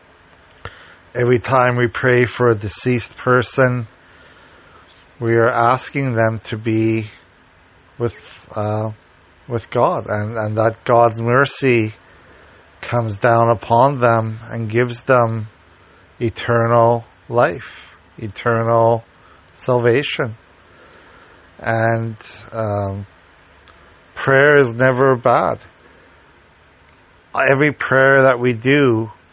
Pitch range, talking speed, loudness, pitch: 100-120 Hz, 90 wpm, -17 LUFS, 115 Hz